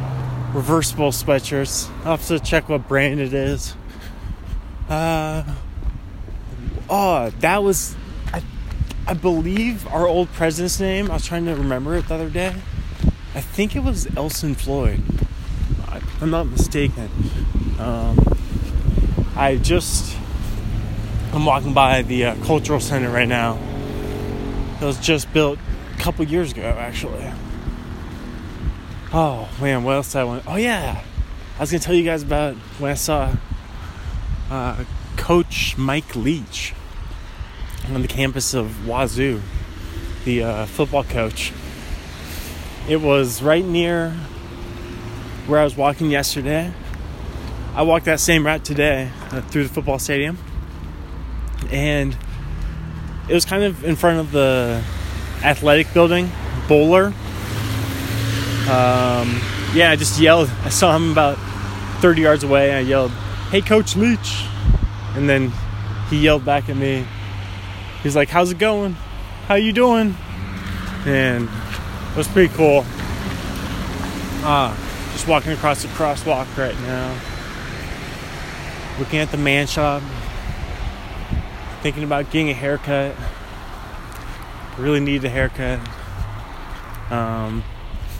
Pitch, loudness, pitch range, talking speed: 125 Hz, -20 LUFS, 95-150 Hz, 125 wpm